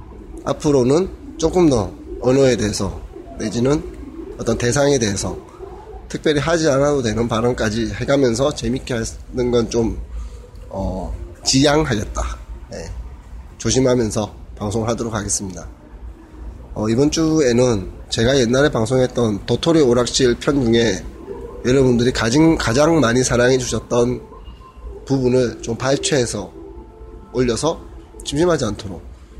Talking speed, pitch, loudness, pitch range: 265 characters per minute, 120 Hz, -18 LUFS, 100-135 Hz